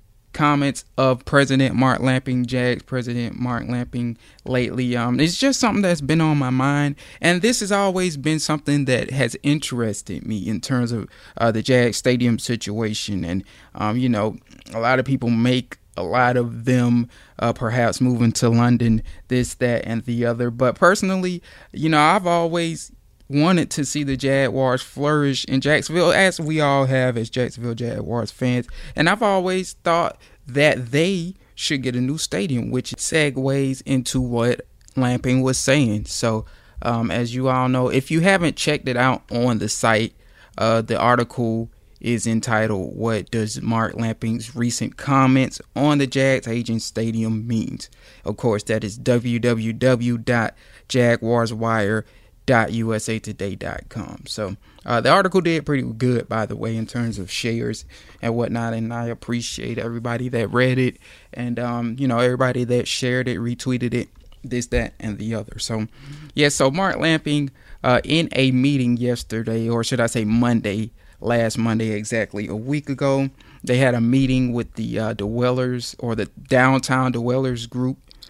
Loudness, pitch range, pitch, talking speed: -21 LUFS, 115-135 Hz, 120 Hz, 165 wpm